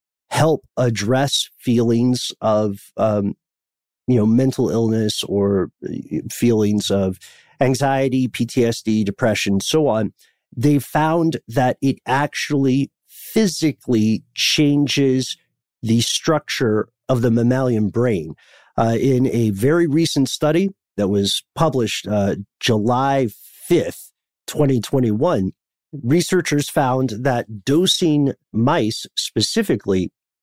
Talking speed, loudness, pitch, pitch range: 100 wpm, -19 LUFS, 125 Hz, 110-140 Hz